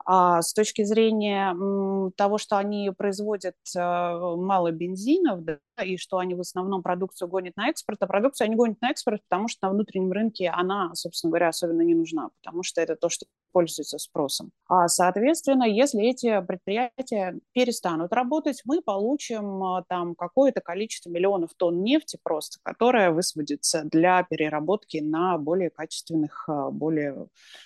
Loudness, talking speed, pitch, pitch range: -25 LUFS, 150 wpm, 190 Hz, 175-220 Hz